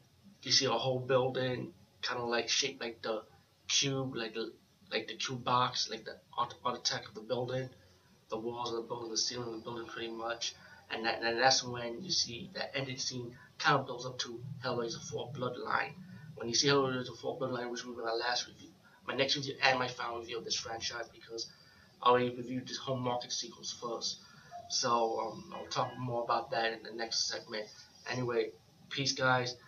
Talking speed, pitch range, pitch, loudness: 205 wpm, 115-130 Hz, 125 Hz, -34 LUFS